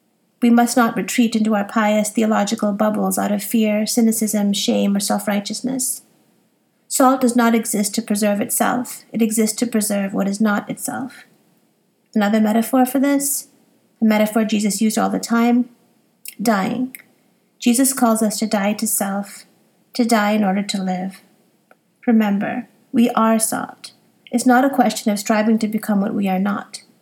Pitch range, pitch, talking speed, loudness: 210-240 Hz, 225 Hz, 160 wpm, -18 LUFS